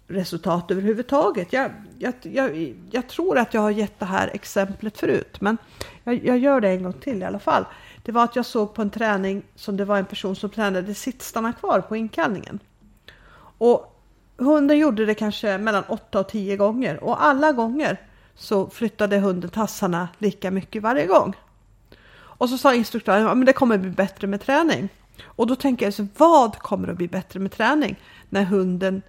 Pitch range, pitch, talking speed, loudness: 195-245 Hz, 215 Hz, 190 wpm, -22 LUFS